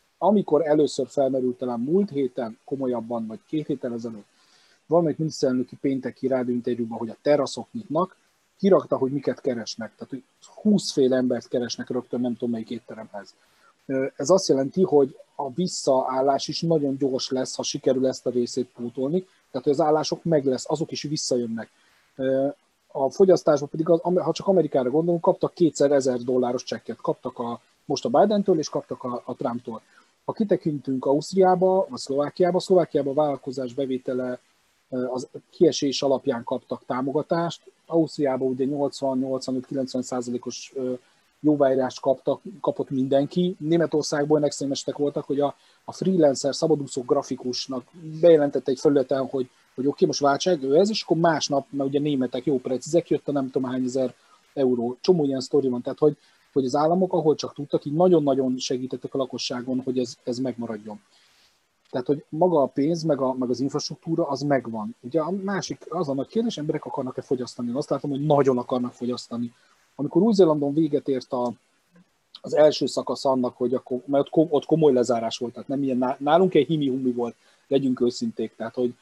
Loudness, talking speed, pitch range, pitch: -24 LUFS, 165 wpm, 125-155 Hz, 135 Hz